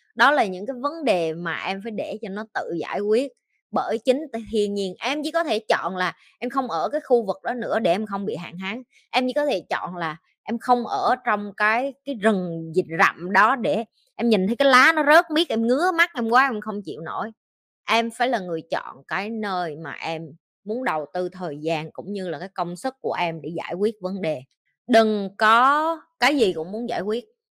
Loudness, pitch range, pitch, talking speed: -23 LUFS, 180-250 Hz, 215 Hz, 235 wpm